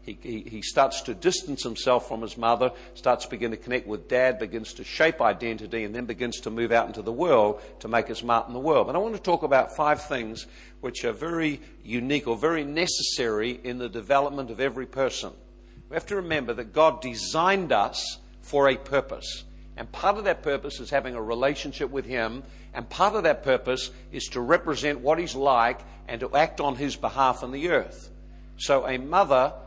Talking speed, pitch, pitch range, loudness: 205 wpm, 130 Hz, 115-145 Hz, -26 LUFS